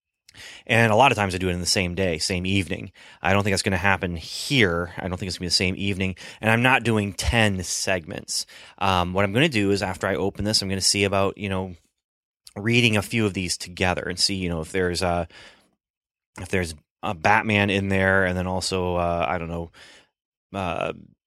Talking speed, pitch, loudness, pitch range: 225 wpm, 95 Hz, -23 LUFS, 90-100 Hz